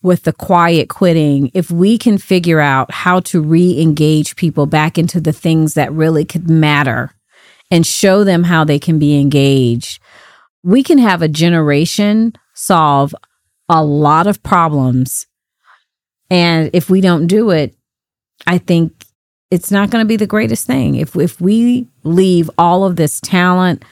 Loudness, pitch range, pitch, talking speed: -12 LUFS, 150-185 Hz, 170 Hz, 160 wpm